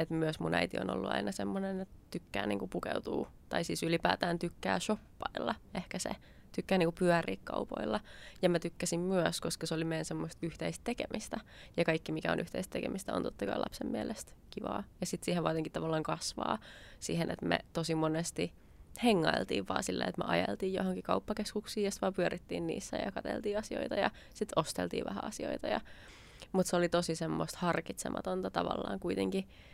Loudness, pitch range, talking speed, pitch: -36 LUFS, 160-185 Hz, 175 wpm, 165 Hz